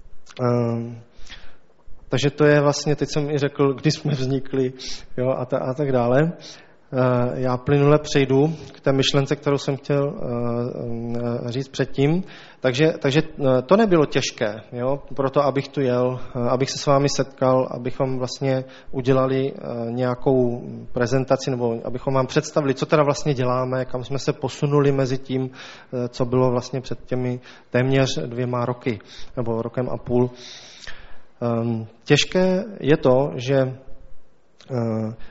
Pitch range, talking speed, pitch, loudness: 125-140 Hz, 135 wpm, 130 Hz, -22 LUFS